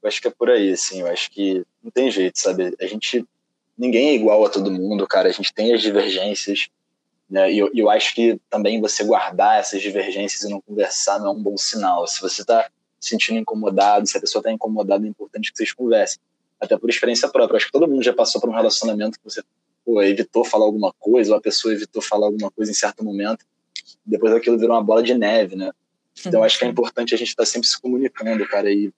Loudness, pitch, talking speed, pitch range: -19 LUFS, 110 Hz, 240 wpm, 100-120 Hz